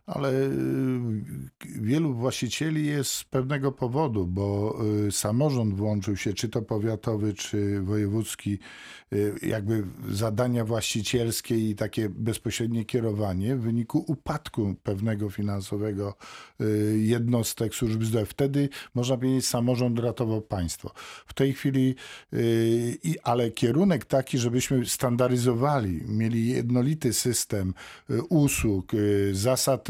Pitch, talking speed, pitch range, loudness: 115 Hz, 100 wpm, 105-130 Hz, -27 LUFS